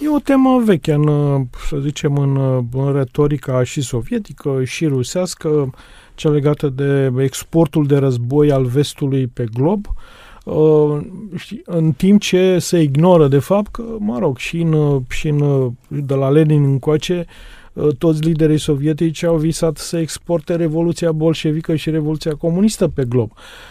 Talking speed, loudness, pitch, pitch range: 140 wpm, -16 LUFS, 155 Hz, 140-170 Hz